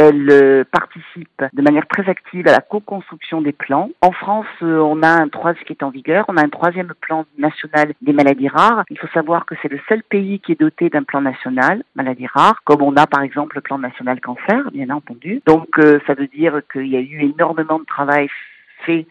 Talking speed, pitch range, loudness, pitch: 215 wpm, 140-170 Hz, -16 LUFS, 155 Hz